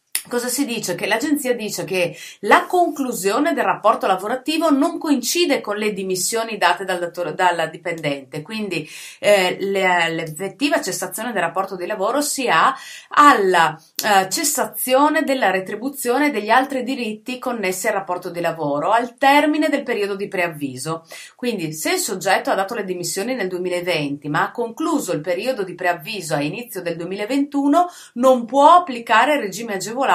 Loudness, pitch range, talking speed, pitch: -19 LUFS, 180-260 Hz, 155 wpm, 210 Hz